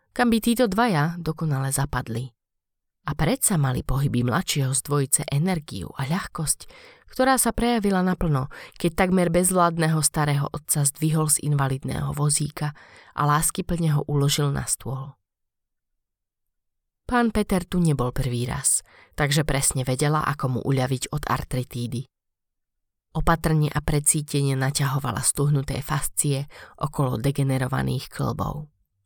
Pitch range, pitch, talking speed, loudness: 135-165 Hz, 145 Hz, 120 wpm, -23 LUFS